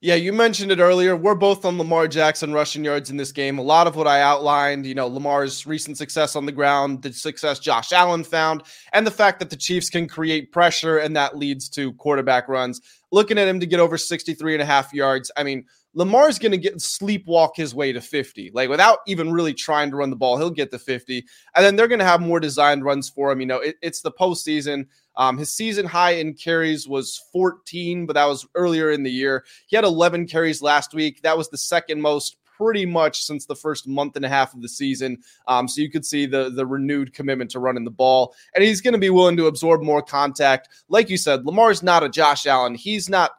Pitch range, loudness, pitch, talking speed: 140-175 Hz, -20 LUFS, 155 Hz, 240 wpm